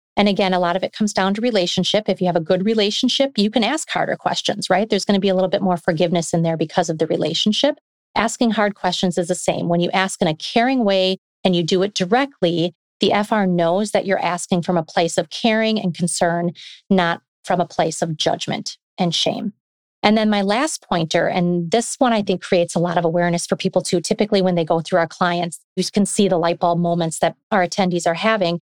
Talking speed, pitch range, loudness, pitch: 235 wpm, 175-205 Hz, -19 LUFS, 185 Hz